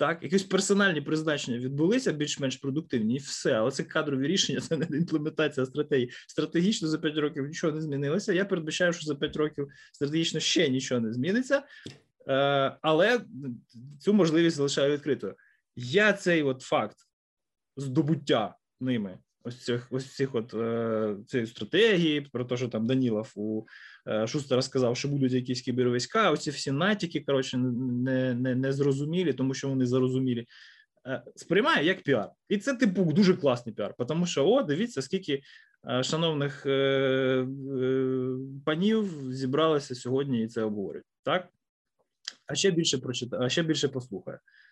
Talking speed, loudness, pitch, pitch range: 145 wpm, -28 LUFS, 140 Hz, 130-160 Hz